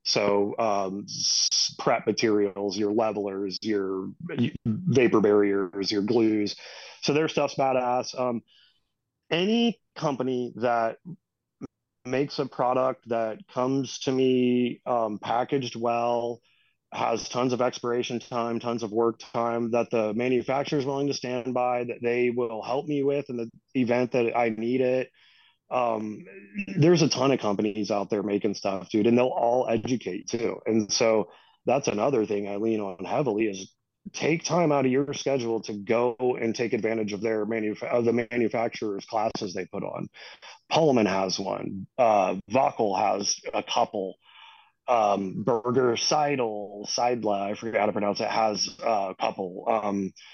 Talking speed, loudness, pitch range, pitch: 155 wpm, -26 LUFS, 105-125 Hz, 120 Hz